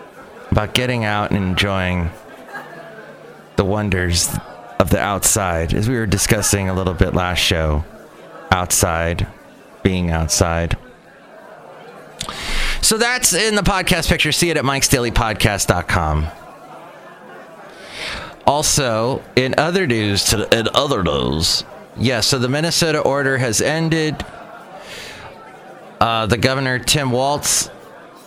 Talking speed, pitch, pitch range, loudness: 120 wpm, 110 Hz, 95-135 Hz, -17 LUFS